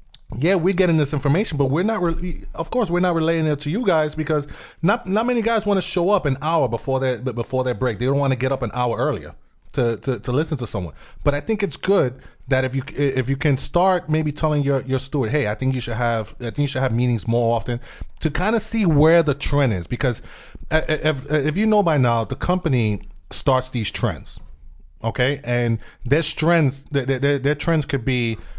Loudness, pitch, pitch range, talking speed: -21 LUFS, 140 Hz, 120-160 Hz, 230 wpm